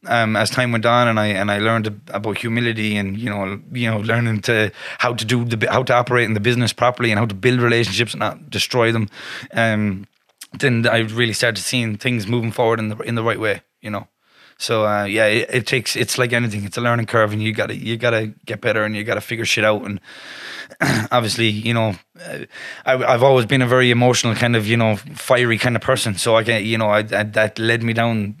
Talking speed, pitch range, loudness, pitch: 245 wpm, 110-120 Hz, -18 LUFS, 115 Hz